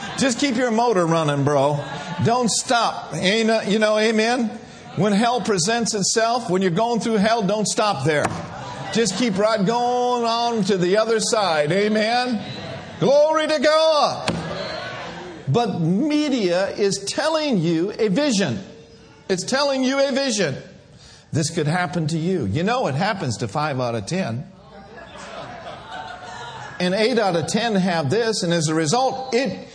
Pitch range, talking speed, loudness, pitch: 175-240 Hz, 150 wpm, -20 LUFS, 215 Hz